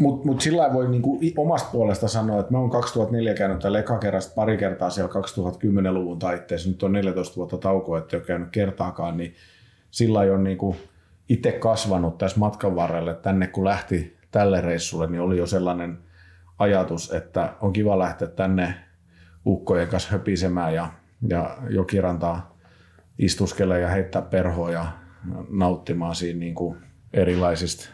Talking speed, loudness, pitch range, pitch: 145 wpm, -24 LUFS, 85-100 Hz, 95 Hz